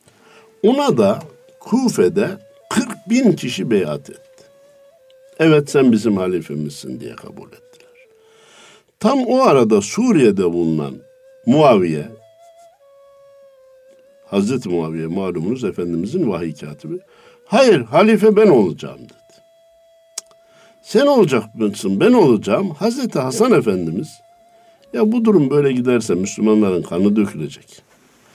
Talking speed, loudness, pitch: 100 wpm, -16 LUFS, 225 Hz